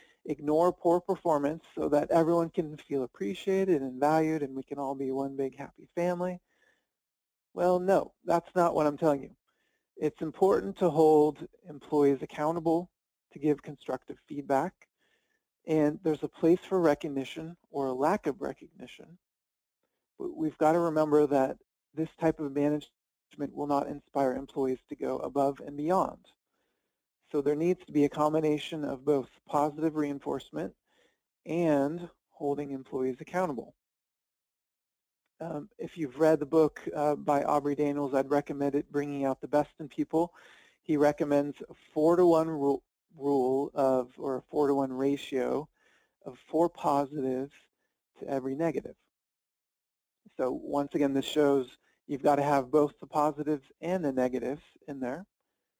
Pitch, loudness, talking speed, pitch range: 150 Hz, -30 LUFS, 145 wpm, 140-160 Hz